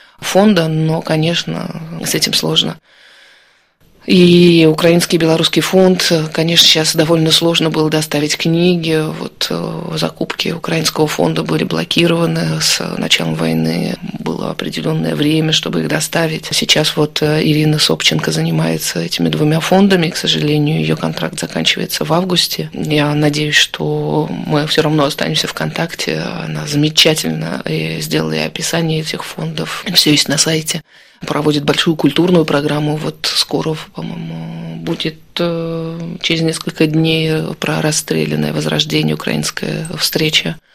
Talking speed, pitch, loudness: 120 wpm, 155 Hz, -14 LUFS